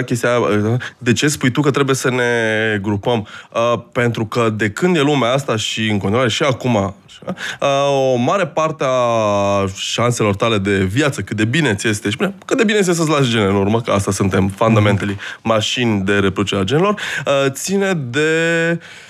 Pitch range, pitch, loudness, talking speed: 105-140 Hz, 120 Hz, -16 LUFS, 170 wpm